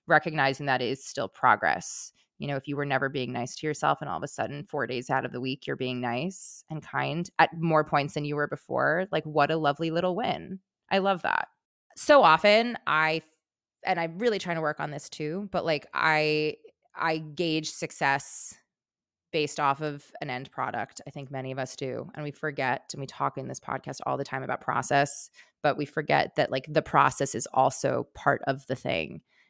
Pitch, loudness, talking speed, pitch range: 150 Hz, -28 LUFS, 210 wpm, 140-165 Hz